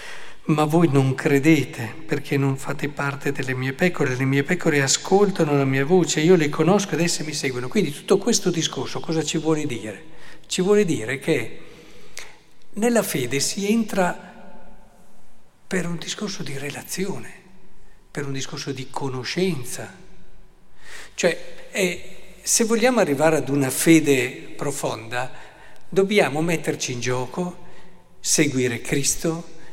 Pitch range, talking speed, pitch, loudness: 140-185 Hz, 135 wpm, 160 Hz, -22 LUFS